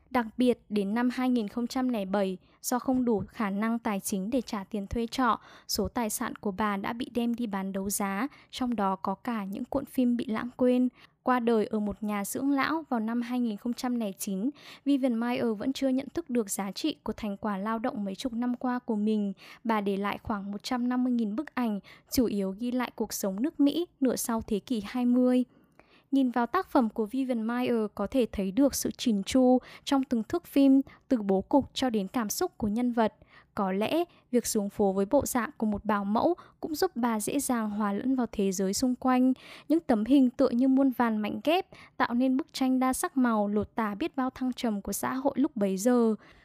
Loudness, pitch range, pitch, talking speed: -29 LUFS, 210-260 Hz, 240 Hz, 220 wpm